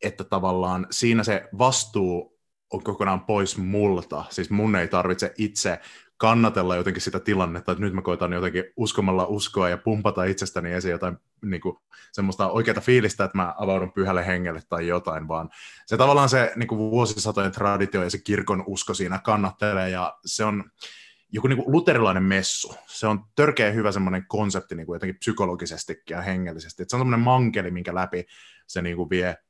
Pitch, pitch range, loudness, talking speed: 95 Hz, 90-105 Hz, -24 LUFS, 175 wpm